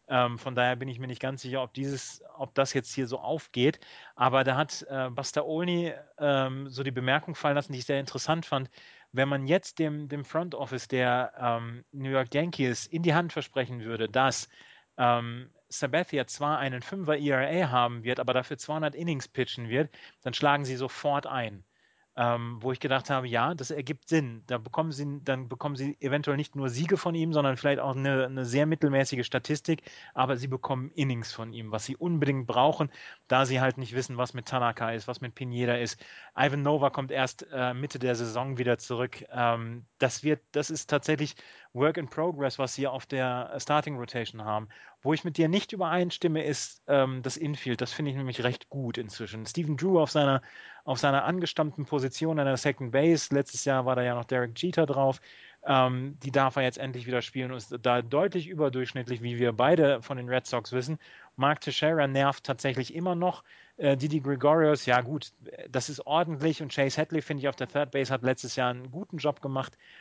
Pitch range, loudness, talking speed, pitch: 125-150 Hz, -29 LUFS, 200 wpm, 135 Hz